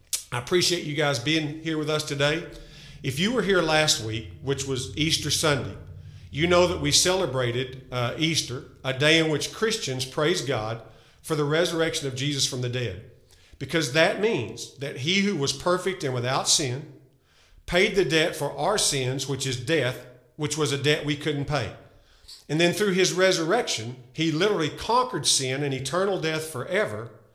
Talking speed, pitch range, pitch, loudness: 180 wpm, 130-160 Hz, 145 Hz, -24 LUFS